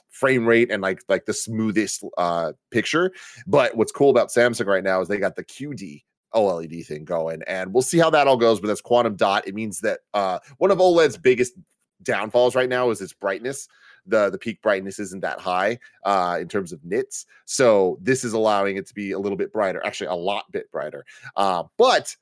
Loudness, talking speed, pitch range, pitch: -22 LUFS, 215 wpm, 95-125 Hz, 110 Hz